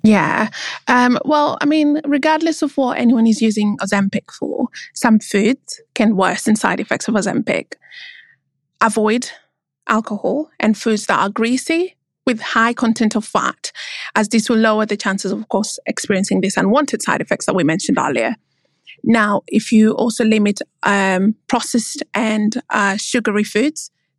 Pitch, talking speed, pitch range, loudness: 225 Hz, 155 wpm, 210-255 Hz, -17 LUFS